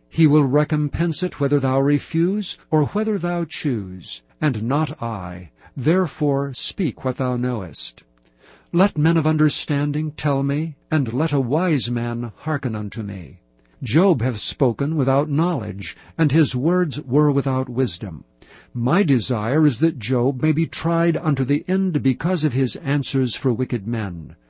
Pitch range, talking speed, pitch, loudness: 120-155 Hz, 150 wpm, 140 Hz, -21 LUFS